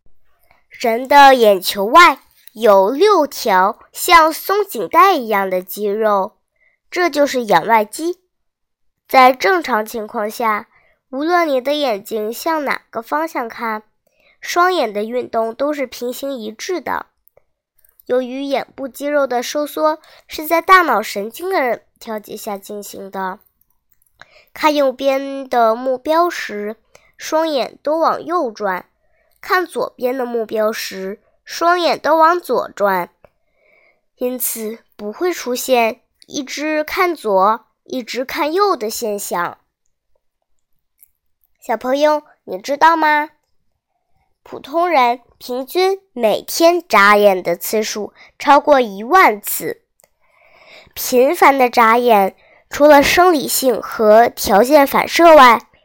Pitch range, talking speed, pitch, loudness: 215-315 Hz, 170 characters per minute, 255 Hz, -15 LUFS